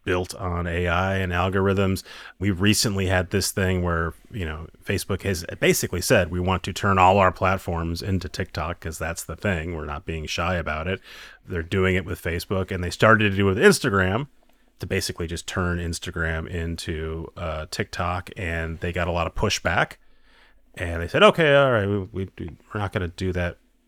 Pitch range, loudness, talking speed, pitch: 85-100 Hz, -23 LUFS, 195 wpm, 90 Hz